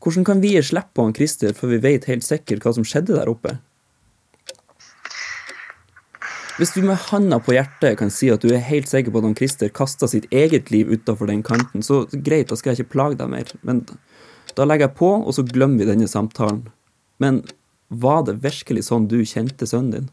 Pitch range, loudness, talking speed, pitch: 115-145 Hz, -19 LUFS, 200 wpm, 130 Hz